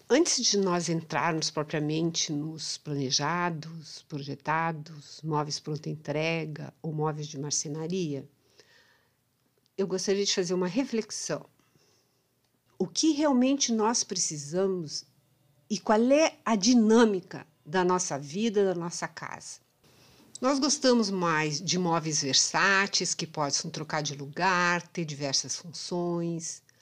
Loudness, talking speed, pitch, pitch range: -28 LUFS, 115 wpm, 165 Hz, 150-190 Hz